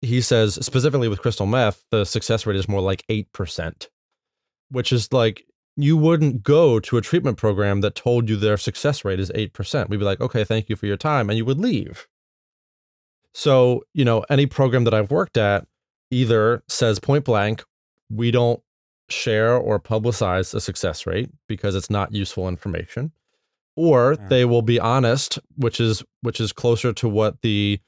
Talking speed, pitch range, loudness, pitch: 180 wpm, 105-125 Hz, -21 LUFS, 115 Hz